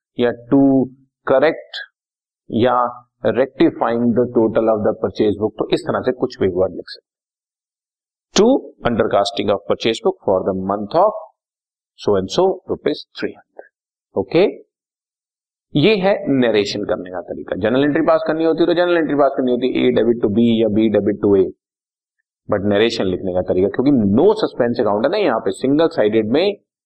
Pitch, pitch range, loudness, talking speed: 120 Hz, 105-135 Hz, -17 LUFS, 175 wpm